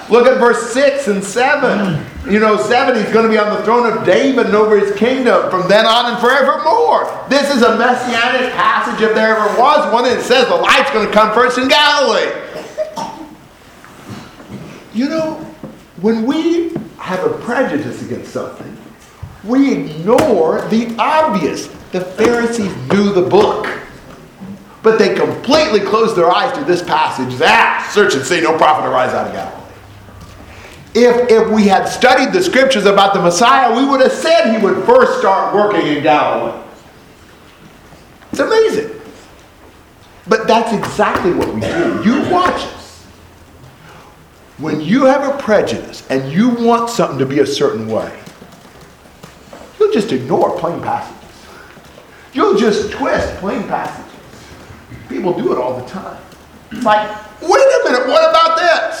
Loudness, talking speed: -13 LUFS, 155 wpm